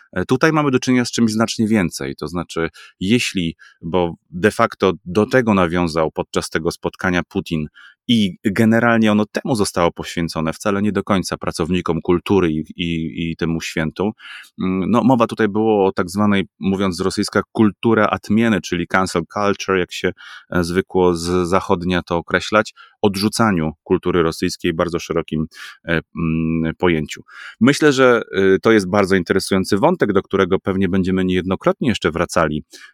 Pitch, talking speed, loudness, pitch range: 95 Hz, 150 wpm, -18 LUFS, 85-105 Hz